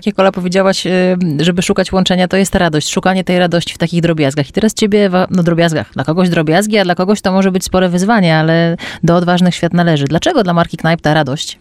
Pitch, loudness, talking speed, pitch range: 180 Hz, -12 LUFS, 220 wpm, 170-190 Hz